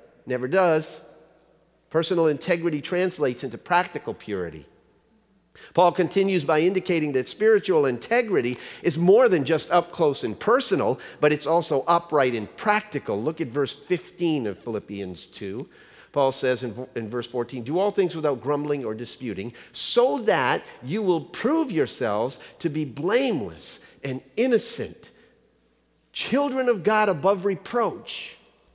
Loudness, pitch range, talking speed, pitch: -24 LUFS, 135-195 Hz, 140 wpm, 165 Hz